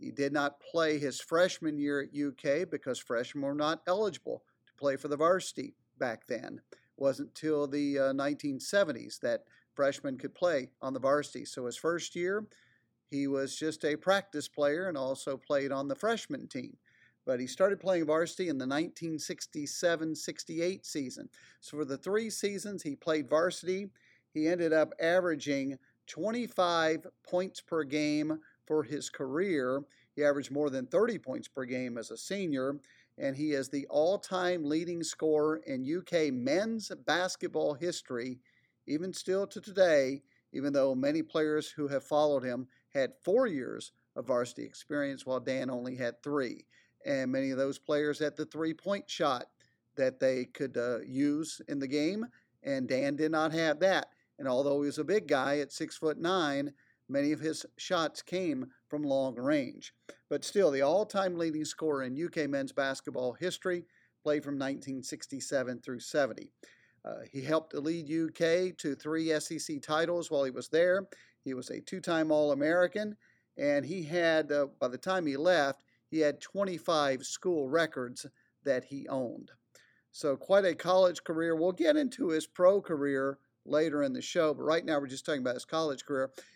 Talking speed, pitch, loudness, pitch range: 170 wpm, 155 Hz, -33 LUFS, 140-180 Hz